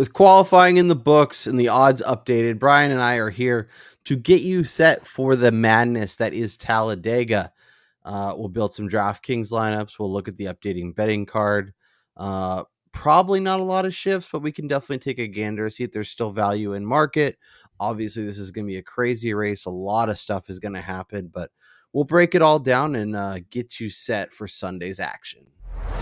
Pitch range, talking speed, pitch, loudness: 100-135 Hz, 210 wpm, 110 Hz, -20 LUFS